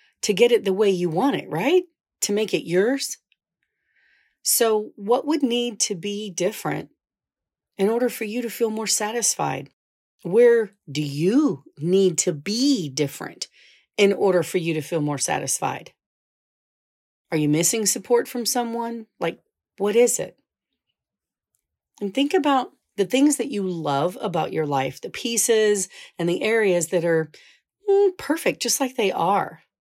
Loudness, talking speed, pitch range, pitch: -22 LUFS, 155 wpm, 180-240 Hz, 210 Hz